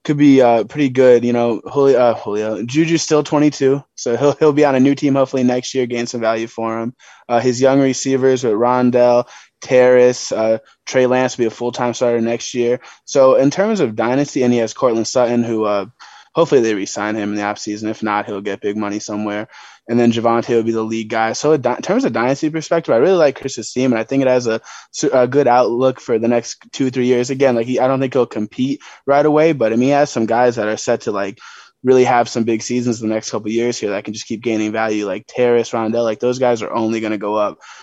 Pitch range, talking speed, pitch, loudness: 115-130 Hz, 250 wpm, 120 Hz, -16 LUFS